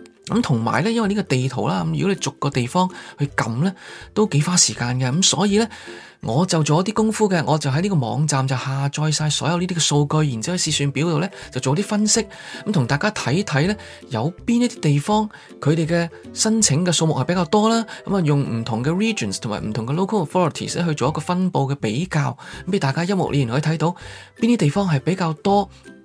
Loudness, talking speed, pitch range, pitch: -20 LUFS, 380 characters per minute, 140-195 Hz, 160 Hz